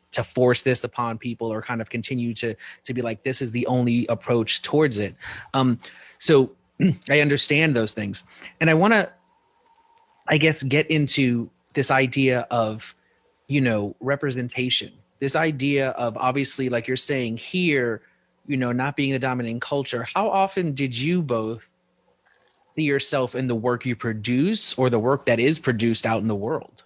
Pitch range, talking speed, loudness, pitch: 120-145 Hz, 170 wpm, -22 LUFS, 130 Hz